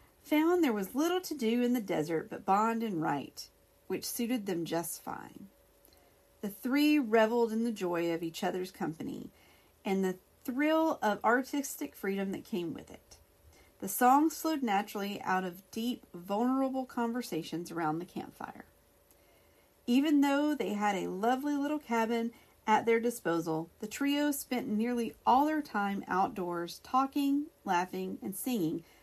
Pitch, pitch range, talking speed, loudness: 230 Hz, 185-270 Hz, 150 wpm, -32 LUFS